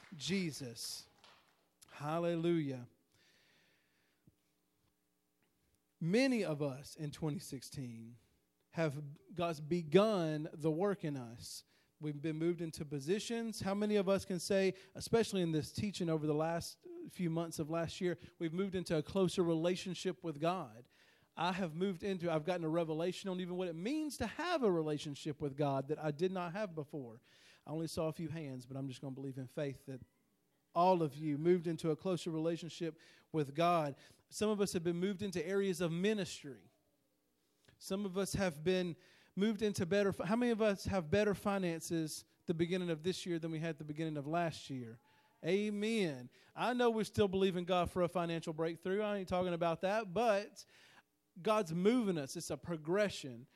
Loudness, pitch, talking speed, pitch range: -38 LUFS, 170 Hz, 175 wpm, 150-190 Hz